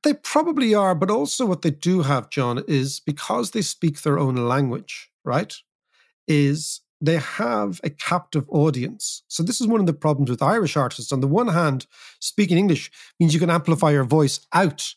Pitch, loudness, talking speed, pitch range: 155 Hz, -21 LUFS, 190 wpm, 140-180 Hz